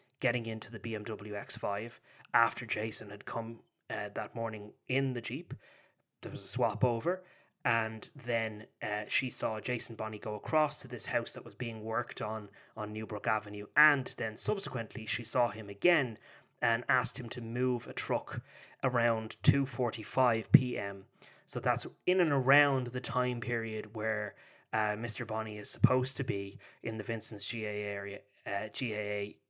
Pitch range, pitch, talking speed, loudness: 110-125 Hz, 115 Hz, 175 wpm, -33 LUFS